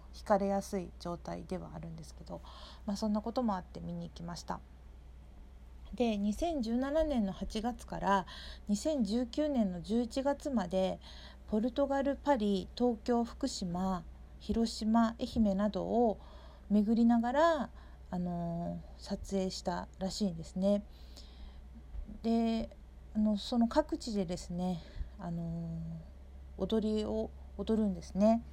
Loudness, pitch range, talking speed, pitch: -34 LUFS, 175-235 Hz, 225 characters per minute, 205 Hz